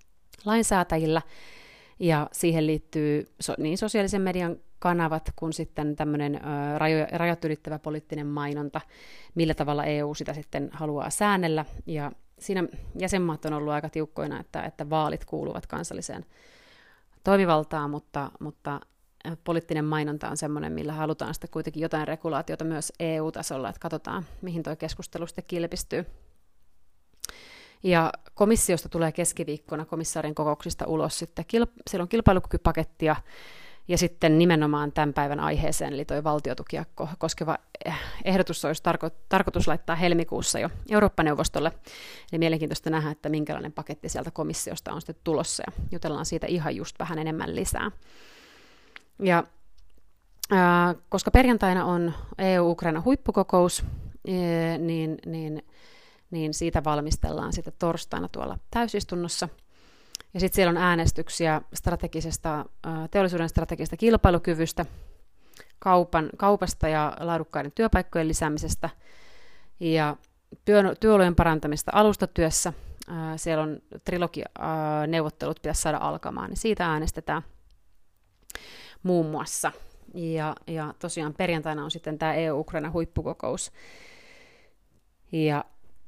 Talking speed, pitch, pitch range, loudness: 110 wpm, 160 Hz, 150-175 Hz, -27 LUFS